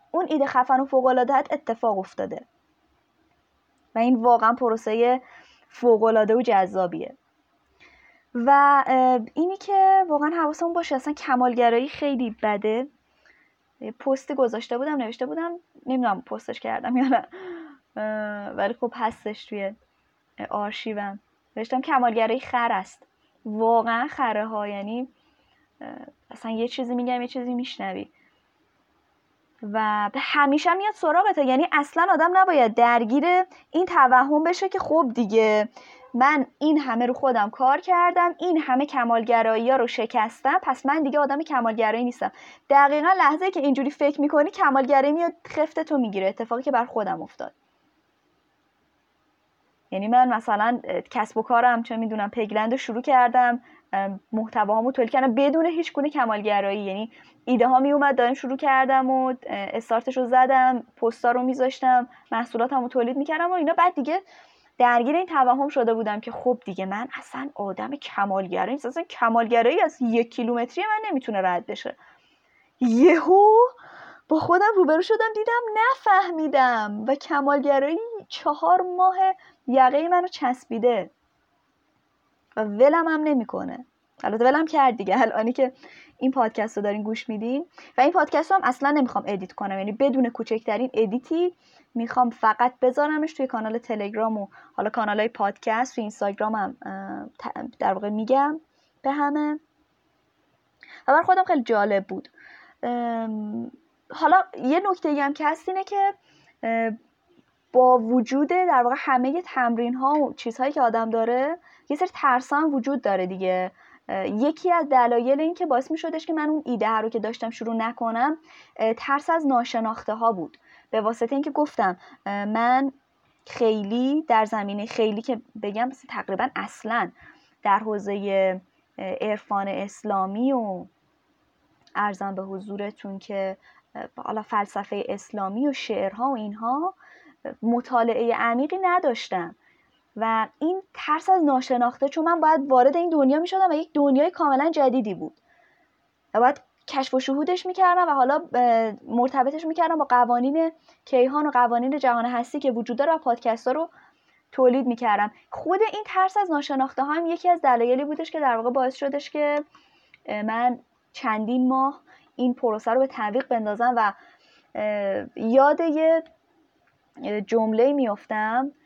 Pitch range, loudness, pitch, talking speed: 230-300 Hz, -23 LUFS, 255 Hz, 140 wpm